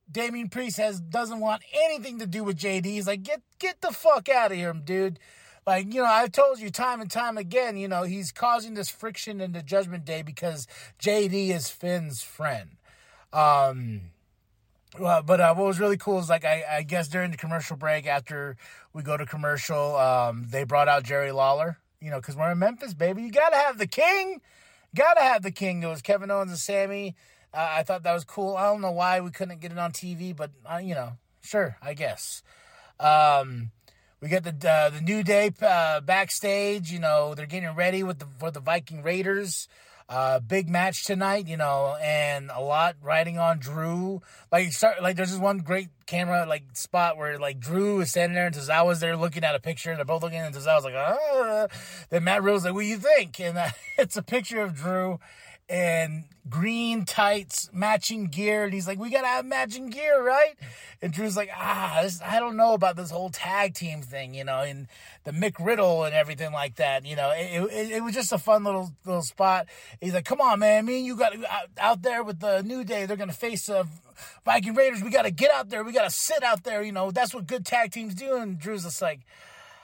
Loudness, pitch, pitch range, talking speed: -26 LUFS, 180 Hz, 155-210 Hz, 220 wpm